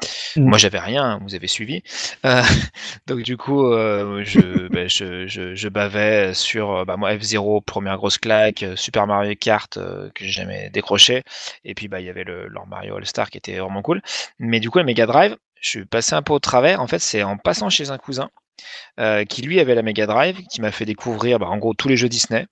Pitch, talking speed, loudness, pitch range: 110 Hz, 225 wpm, -19 LUFS, 100-125 Hz